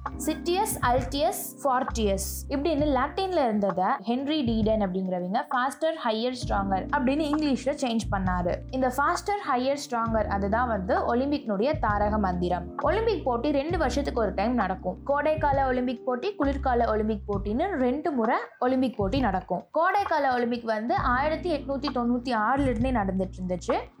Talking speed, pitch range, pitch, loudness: 135 wpm, 215-285 Hz, 255 Hz, -27 LUFS